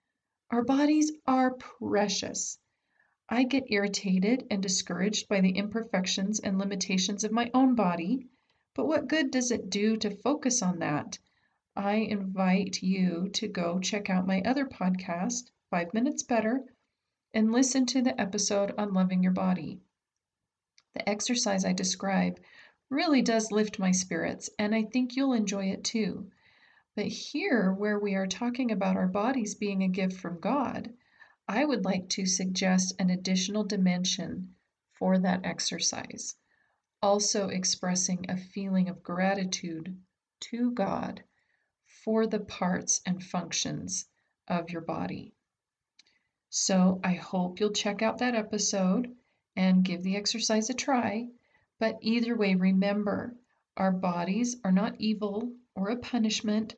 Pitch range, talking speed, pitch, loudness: 185-230 Hz, 140 wpm, 205 Hz, -29 LUFS